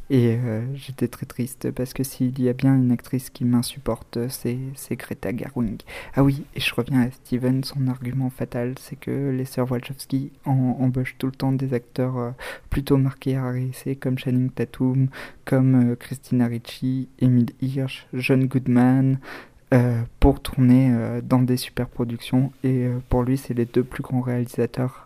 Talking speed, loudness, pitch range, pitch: 175 wpm, -23 LUFS, 120-135 Hz, 130 Hz